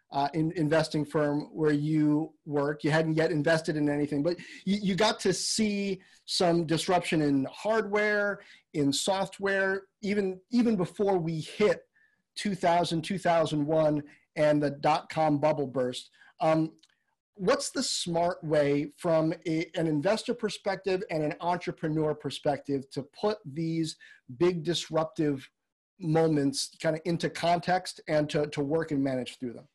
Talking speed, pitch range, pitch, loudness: 140 wpm, 150-190 Hz, 160 Hz, -29 LUFS